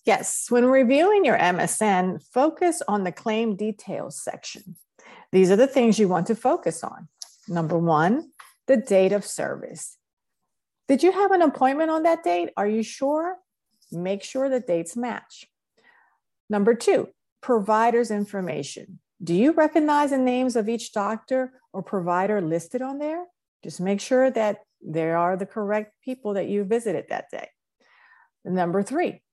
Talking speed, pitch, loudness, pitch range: 155 wpm, 220 Hz, -23 LUFS, 190-265 Hz